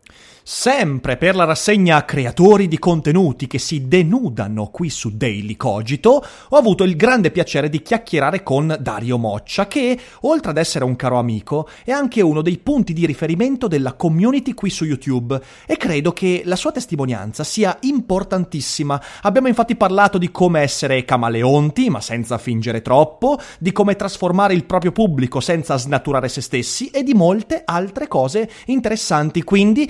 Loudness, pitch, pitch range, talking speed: -17 LUFS, 170 Hz, 135-210 Hz, 160 wpm